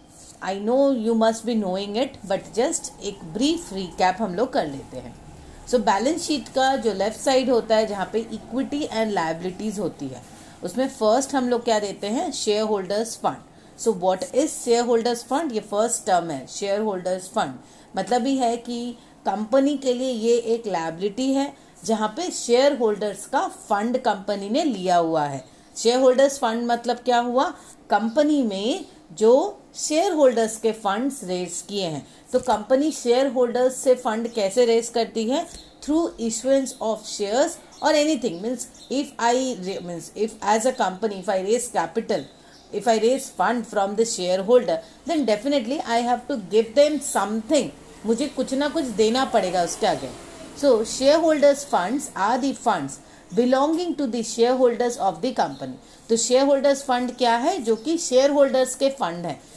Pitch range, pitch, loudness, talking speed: 210-270 Hz, 235 Hz, -23 LUFS, 175 wpm